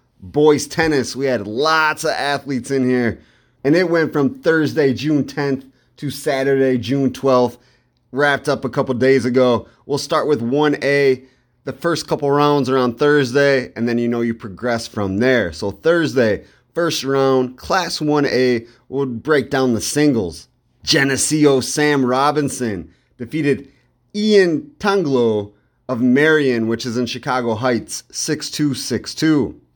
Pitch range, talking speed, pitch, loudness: 125-150 Hz, 145 wpm, 135 Hz, -17 LUFS